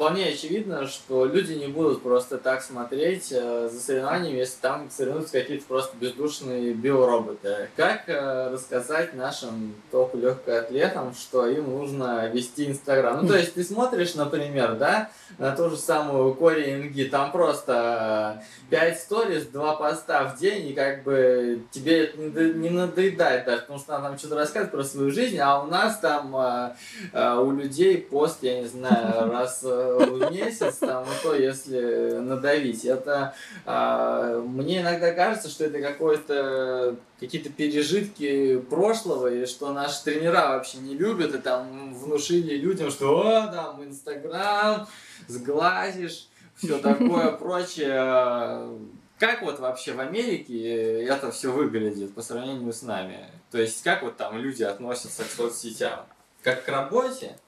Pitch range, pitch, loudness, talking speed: 125-160 Hz, 140 Hz, -25 LUFS, 145 wpm